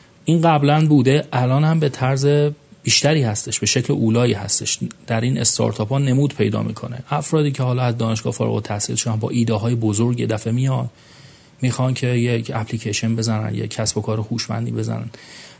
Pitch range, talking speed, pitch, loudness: 110-135 Hz, 175 wpm, 120 Hz, -19 LUFS